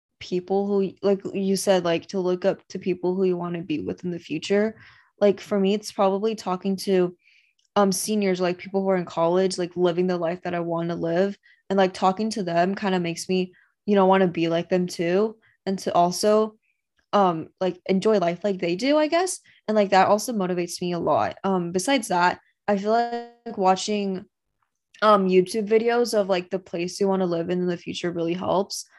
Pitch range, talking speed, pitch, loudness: 180-205 Hz, 215 wpm, 190 Hz, -23 LUFS